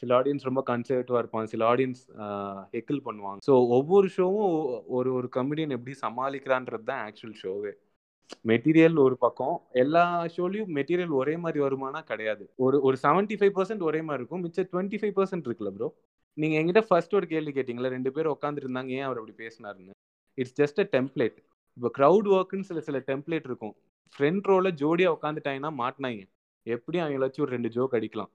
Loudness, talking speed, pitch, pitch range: -27 LUFS, 165 wpm, 135 Hz, 125-170 Hz